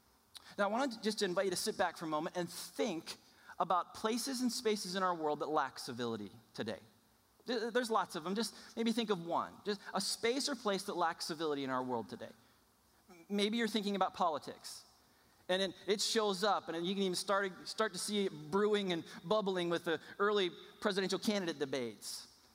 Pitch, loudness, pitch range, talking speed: 195 Hz, -37 LUFS, 170-215 Hz, 195 wpm